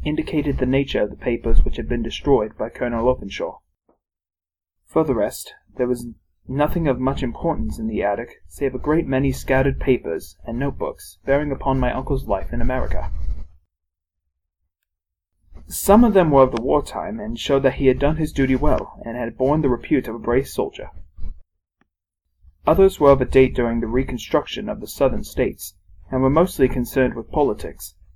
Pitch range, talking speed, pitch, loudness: 85-135 Hz, 180 wpm, 125 Hz, -21 LUFS